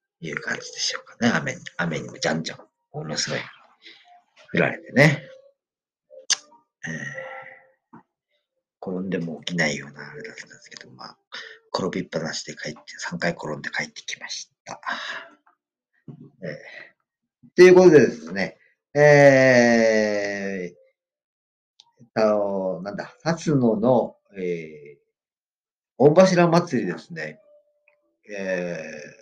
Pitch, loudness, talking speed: 175 Hz, -21 LUFS, 225 characters per minute